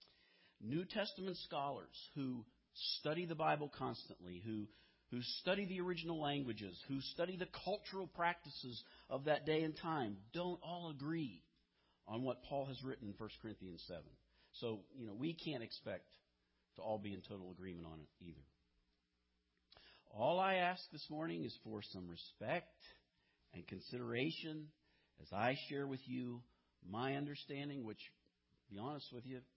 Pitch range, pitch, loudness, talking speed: 95-155 Hz, 125 Hz, -45 LUFS, 150 wpm